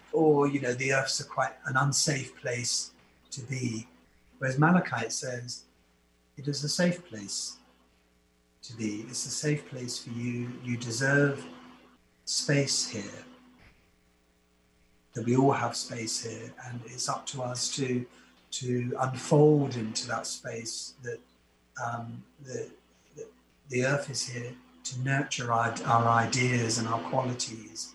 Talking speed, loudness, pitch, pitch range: 140 wpm, -29 LUFS, 120 Hz, 85-130 Hz